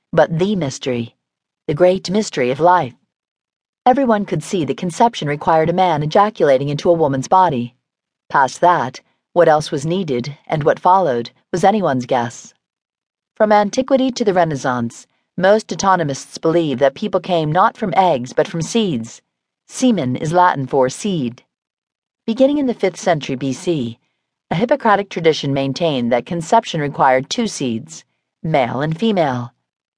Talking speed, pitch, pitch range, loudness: 145 wpm, 170 Hz, 135-200 Hz, -17 LUFS